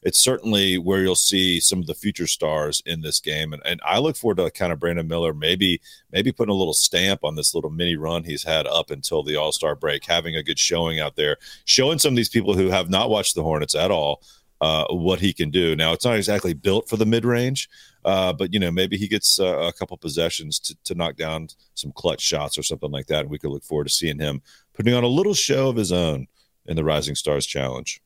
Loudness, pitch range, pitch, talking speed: -21 LUFS, 80-100 Hz, 85 Hz, 250 wpm